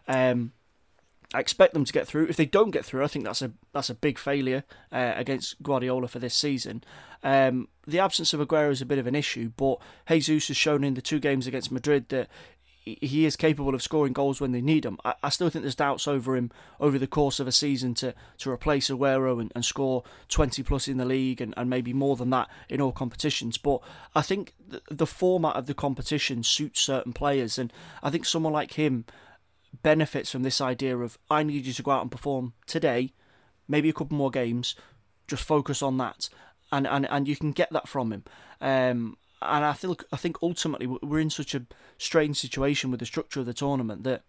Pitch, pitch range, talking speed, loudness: 140 Hz, 130-150 Hz, 220 wpm, -27 LUFS